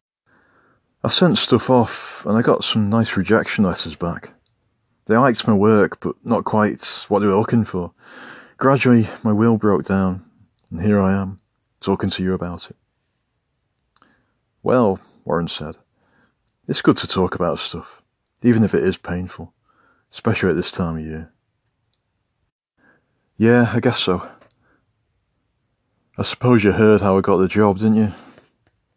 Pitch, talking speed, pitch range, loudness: 105 Hz, 150 wpm, 95-115 Hz, -18 LUFS